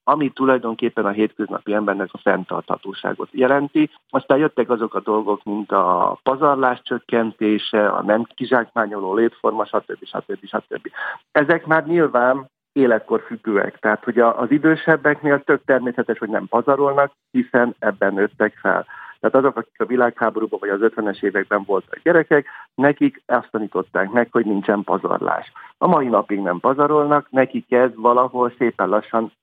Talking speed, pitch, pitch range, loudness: 145 wpm, 120 Hz, 110-140 Hz, -19 LUFS